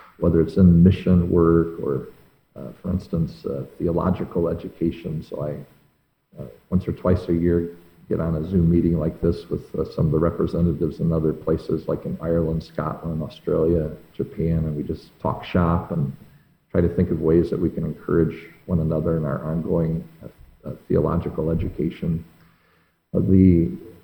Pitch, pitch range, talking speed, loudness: 85 Hz, 80-85 Hz, 170 wpm, -22 LUFS